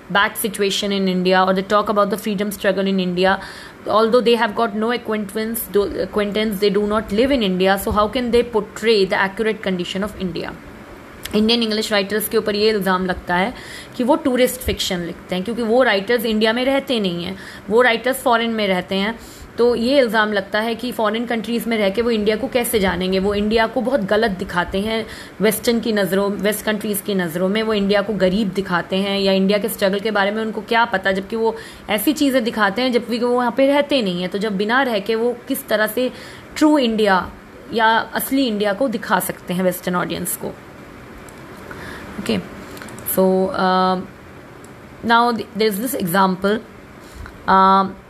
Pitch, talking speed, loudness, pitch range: 215 Hz, 190 wpm, -18 LUFS, 195-230 Hz